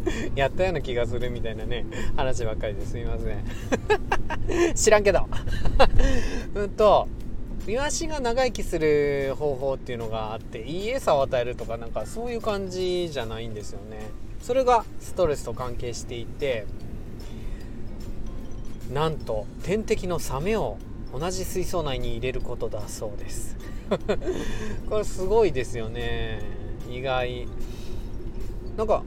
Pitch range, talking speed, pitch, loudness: 115-170 Hz, 275 characters per minute, 120 Hz, -27 LUFS